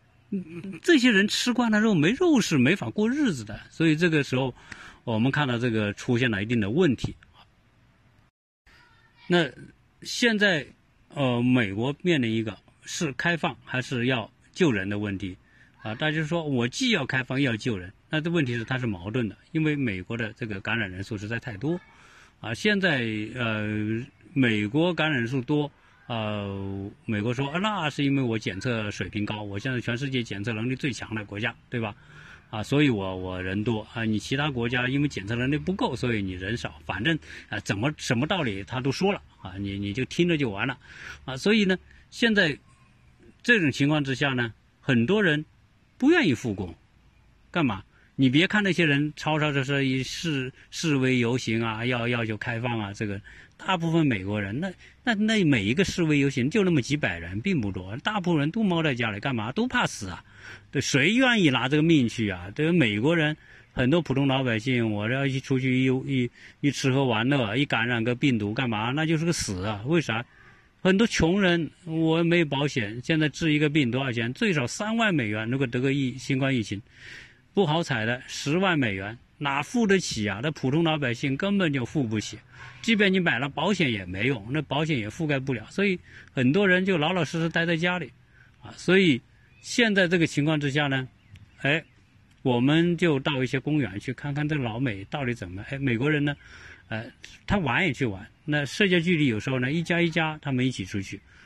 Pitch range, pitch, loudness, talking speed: 115-160 Hz, 130 Hz, -25 LUFS, 280 characters per minute